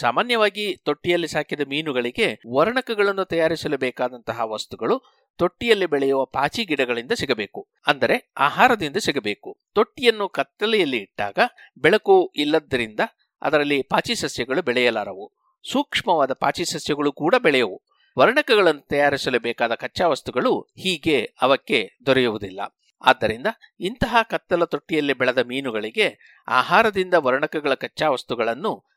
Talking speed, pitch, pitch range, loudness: 100 wpm, 160 Hz, 135-215 Hz, -21 LUFS